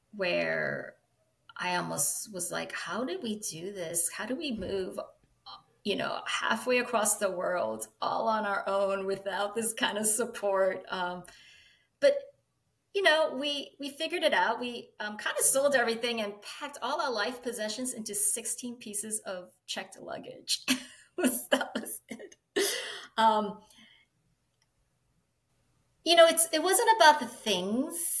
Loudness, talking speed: -28 LUFS, 145 wpm